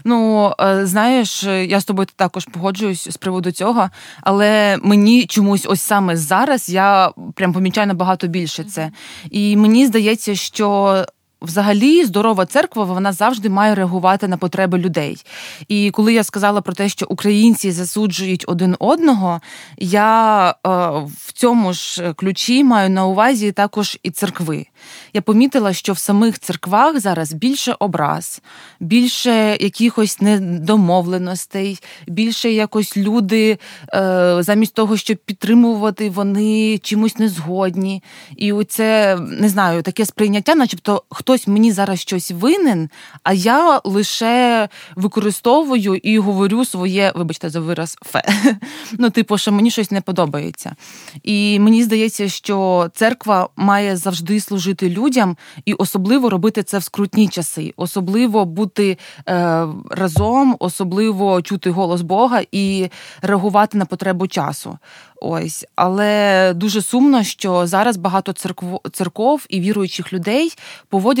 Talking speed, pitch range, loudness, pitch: 130 wpm, 185-220 Hz, -16 LUFS, 200 Hz